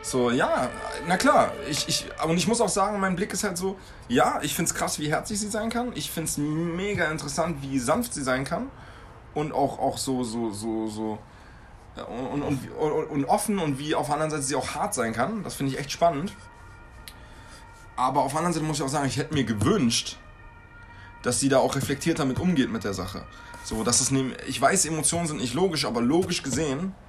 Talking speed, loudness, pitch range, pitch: 215 wpm, -26 LUFS, 125-170 Hz, 145 Hz